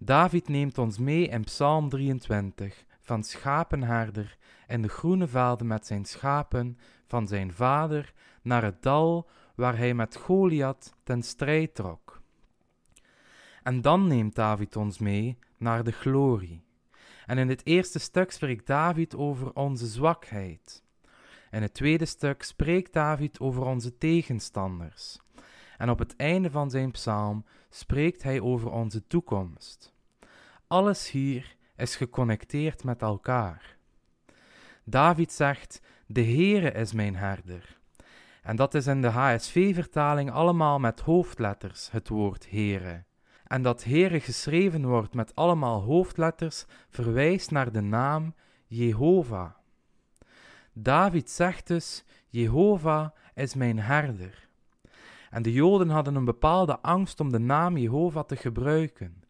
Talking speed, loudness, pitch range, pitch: 130 wpm, -27 LUFS, 115-155 Hz, 130 Hz